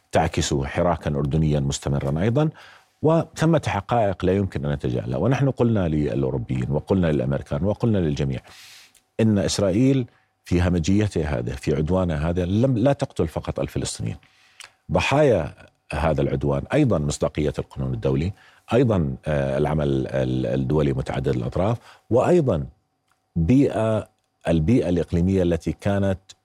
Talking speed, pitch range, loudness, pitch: 110 wpm, 70-105 Hz, -22 LUFS, 85 Hz